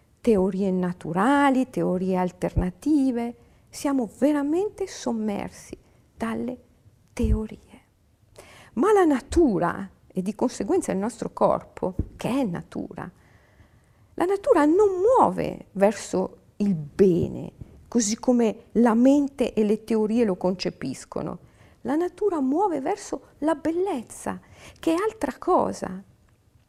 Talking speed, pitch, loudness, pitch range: 105 wpm, 240 Hz, -24 LUFS, 195-320 Hz